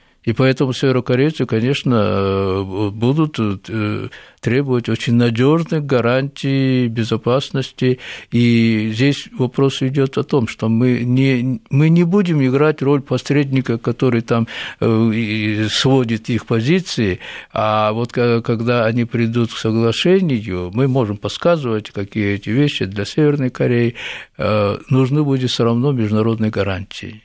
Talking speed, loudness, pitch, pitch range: 115 wpm, -17 LUFS, 120 Hz, 110-135 Hz